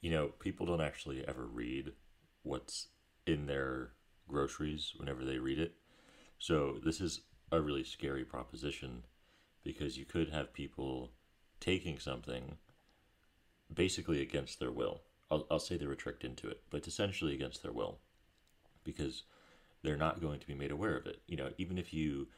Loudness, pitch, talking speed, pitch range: -40 LUFS, 75 Hz, 165 wpm, 65-80 Hz